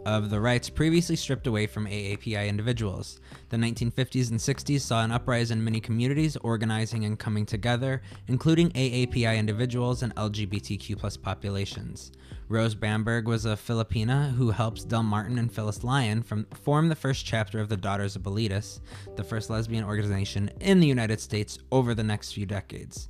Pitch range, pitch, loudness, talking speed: 105-125 Hz, 110 Hz, -28 LUFS, 165 wpm